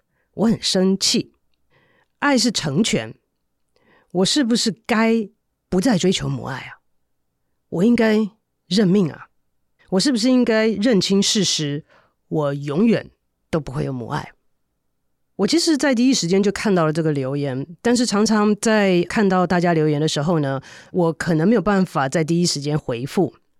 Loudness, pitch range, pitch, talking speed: -19 LUFS, 145-220 Hz, 185 Hz, 230 characters per minute